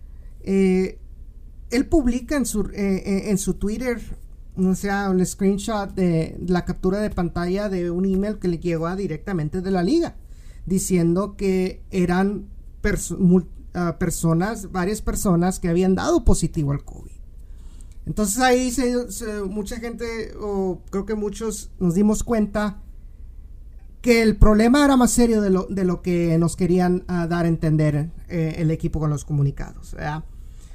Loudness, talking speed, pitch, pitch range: -22 LUFS, 160 wpm, 185 Hz, 170-210 Hz